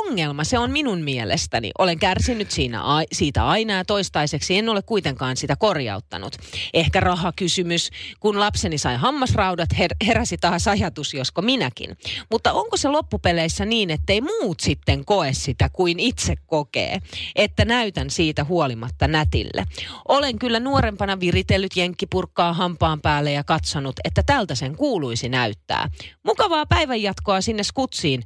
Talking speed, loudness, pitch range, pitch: 140 wpm, -21 LUFS, 145-210 Hz, 175 Hz